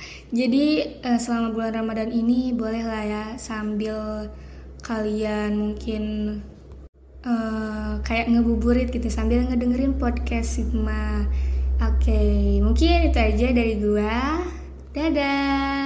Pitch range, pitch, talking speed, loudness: 210-245 Hz, 225 Hz, 100 wpm, -23 LUFS